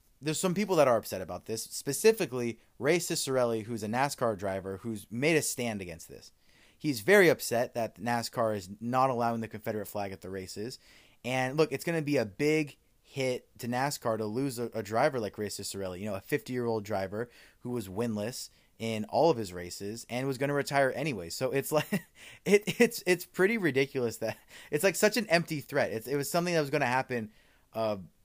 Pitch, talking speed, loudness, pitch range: 120 Hz, 210 wpm, -30 LUFS, 110-145 Hz